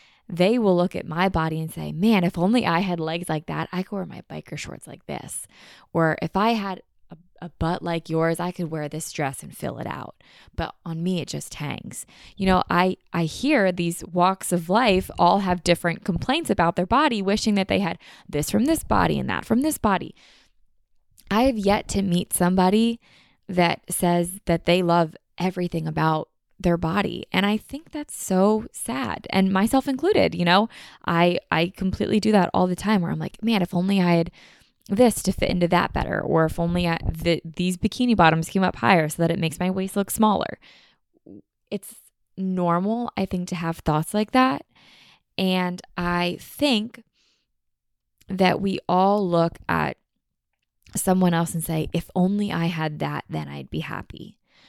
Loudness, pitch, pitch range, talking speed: -23 LUFS, 180 Hz, 170-200 Hz, 190 wpm